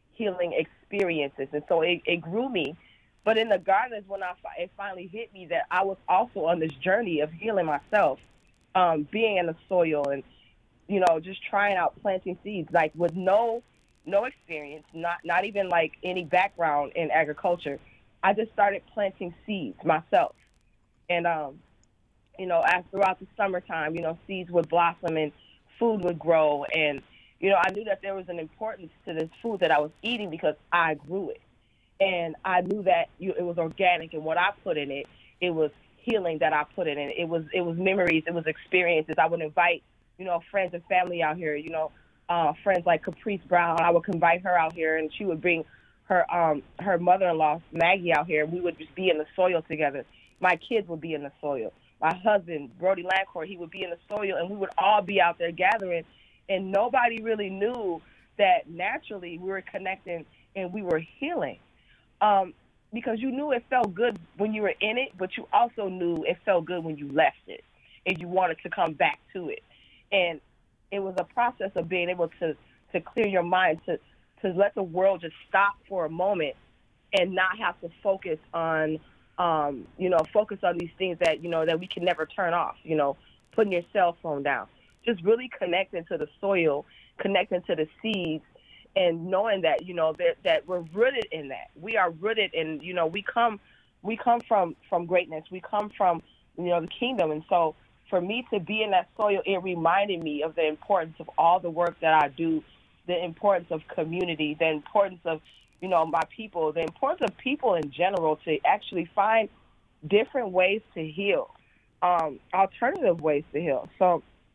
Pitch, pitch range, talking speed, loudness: 175 Hz, 160-195 Hz, 200 wpm, -27 LUFS